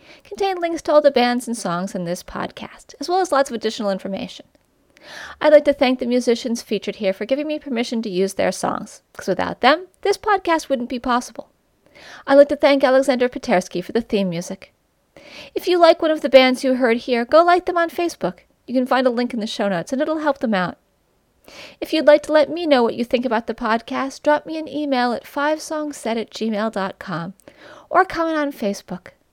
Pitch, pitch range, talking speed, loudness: 265 Hz, 225-300 Hz, 215 wpm, -19 LUFS